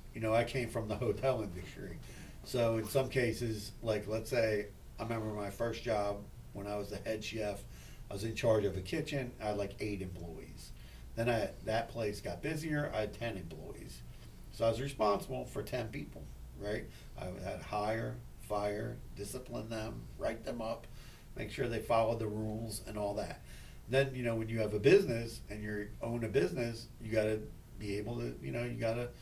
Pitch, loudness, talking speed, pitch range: 110 Hz, -37 LUFS, 200 wpm, 100-115 Hz